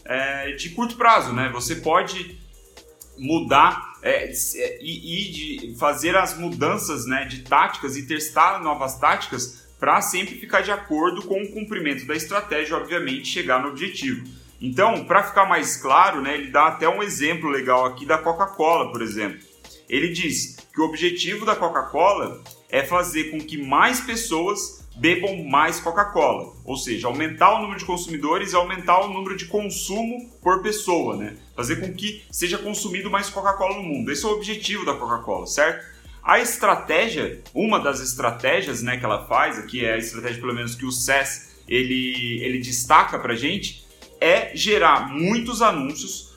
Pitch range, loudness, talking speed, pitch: 135-195 Hz, -22 LUFS, 165 wpm, 165 Hz